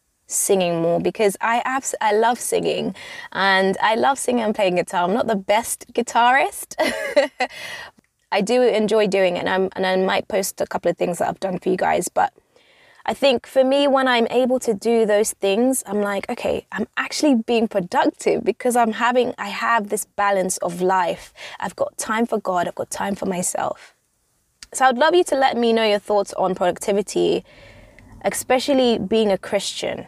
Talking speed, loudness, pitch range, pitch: 190 wpm, -20 LUFS, 195-255 Hz, 225 Hz